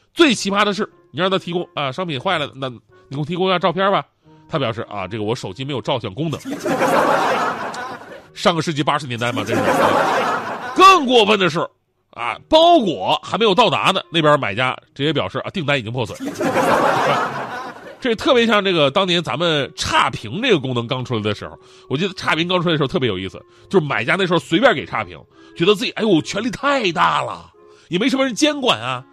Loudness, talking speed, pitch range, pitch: -18 LUFS, 310 characters per minute, 130-195 Hz, 165 Hz